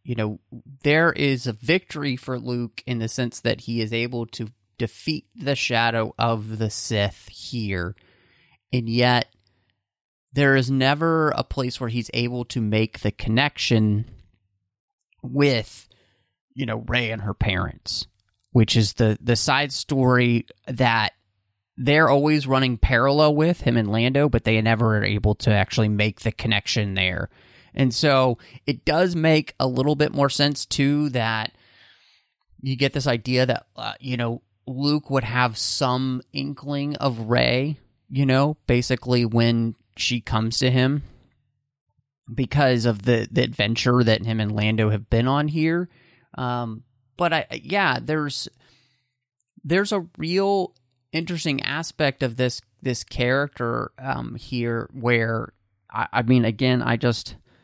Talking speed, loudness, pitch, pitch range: 145 wpm, -22 LUFS, 125 Hz, 110-140 Hz